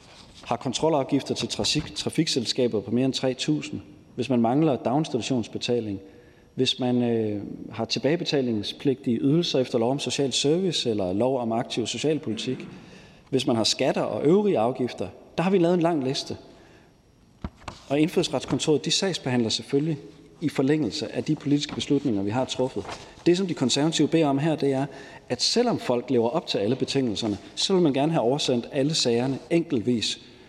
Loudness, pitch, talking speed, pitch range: -25 LUFS, 130 Hz, 165 wpm, 120-150 Hz